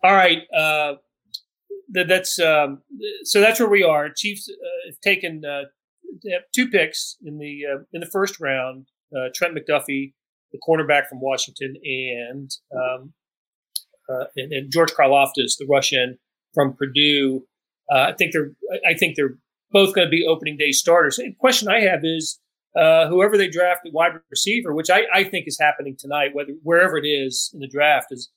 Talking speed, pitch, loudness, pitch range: 180 wpm, 155 Hz, -19 LUFS, 140-185 Hz